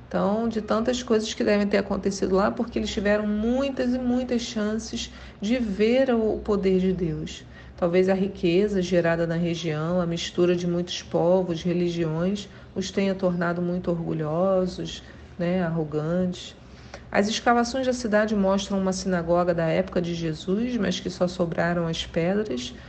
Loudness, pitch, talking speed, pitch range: -25 LUFS, 185 Hz, 150 wpm, 175-210 Hz